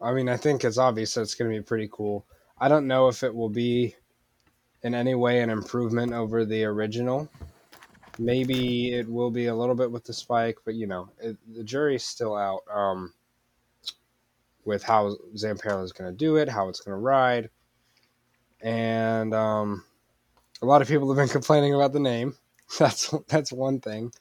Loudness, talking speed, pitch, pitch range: -26 LUFS, 190 wpm, 120 Hz, 110-130 Hz